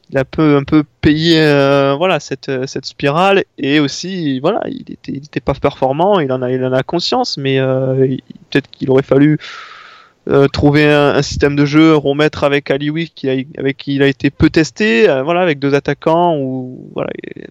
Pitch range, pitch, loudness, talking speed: 135-170 Hz, 145 Hz, -14 LUFS, 200 wpm